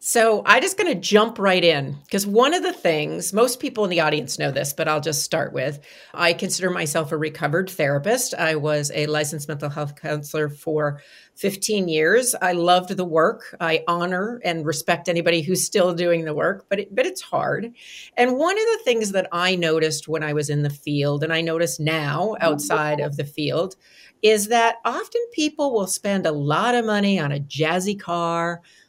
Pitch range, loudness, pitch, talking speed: 155-205 Hz, -21 LUFS, 170 Hz, 200 wpm